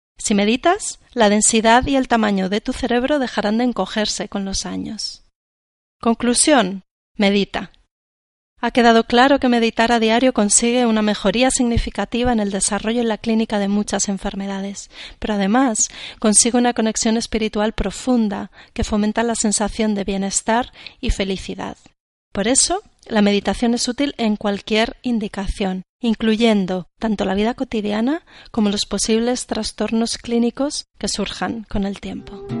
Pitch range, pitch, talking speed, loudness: 200-240 Hz, 220 Hz, 140 wpm, -18 LUFS